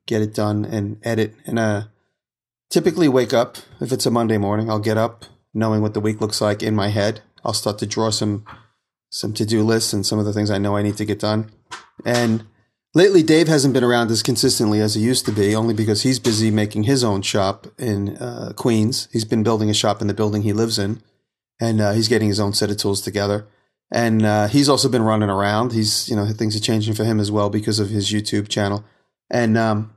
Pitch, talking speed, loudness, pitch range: 110 Hz, 230 wpm, -19 LUFS, 105-115 Hz